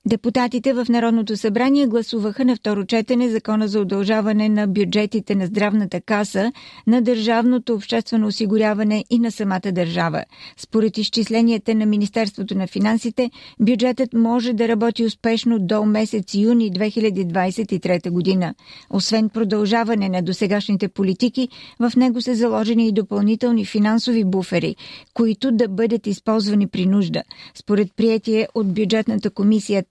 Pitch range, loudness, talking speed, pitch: 205-230 Hz, -19 LUFS, 130 wpm, 220 Hz